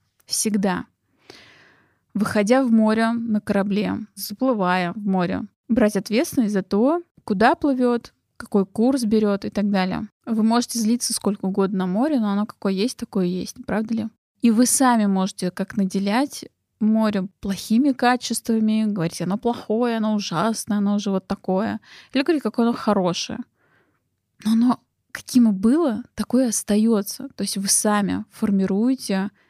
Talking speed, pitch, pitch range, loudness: 150 wpm, 215 Hz, 200-235 Hz, -21 LUFS